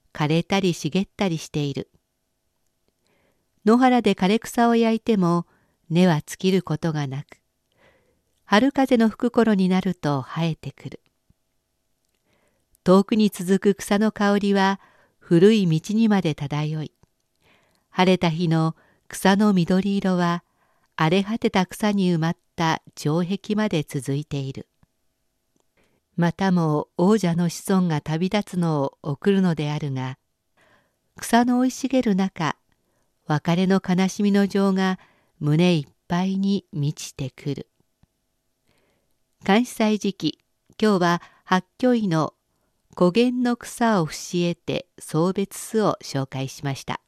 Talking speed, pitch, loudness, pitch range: 225 characters per minute, 185 Hz, -22 LUFS, 155-205 Hz